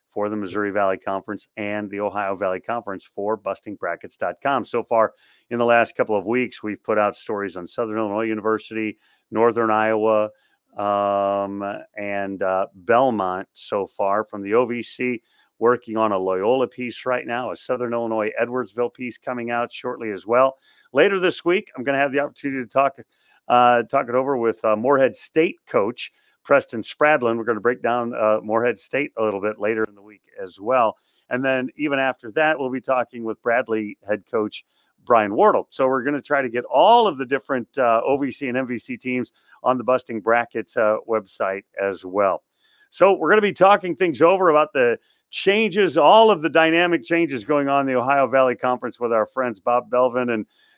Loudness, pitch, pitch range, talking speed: -21 LUFS, 120 Hz, 105-135 Hz, 190 wpm